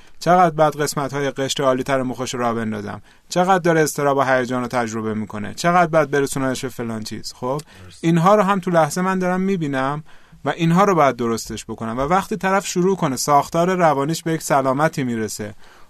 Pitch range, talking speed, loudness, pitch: 120-170 Hz, 185 wpm, -19 LUFS, 140 Hz